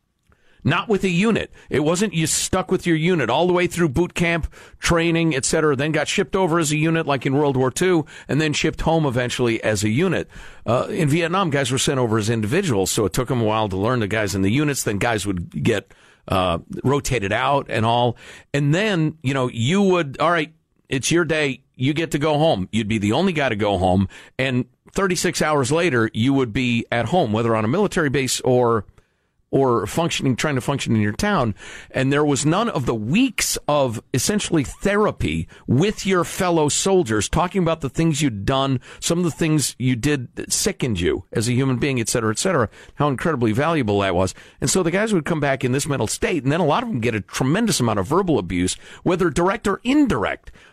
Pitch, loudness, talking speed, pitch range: 145 Hz, -20 LUFS, 225 wpm, 120-170 Hz